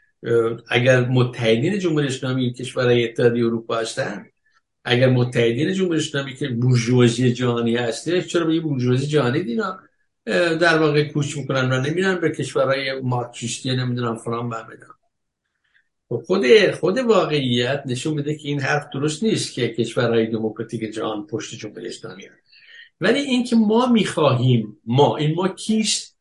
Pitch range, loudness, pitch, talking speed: 120-160 Hz, -20 LUFS, 130 Hz, 135 wpm